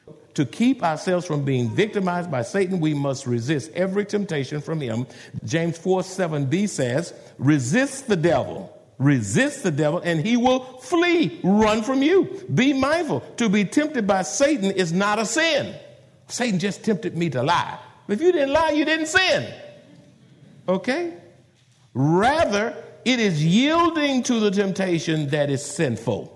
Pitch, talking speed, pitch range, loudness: 185 Hz, 155 wpm, 150-250 Hz, -22 LUFS